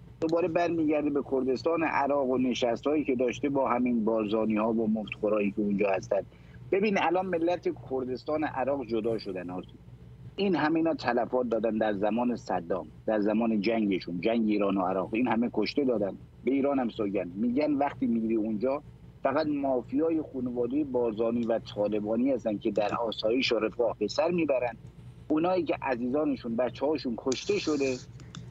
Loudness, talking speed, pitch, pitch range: -29 LUFS, 155 wpm, 125 Hz, 110-150 Hz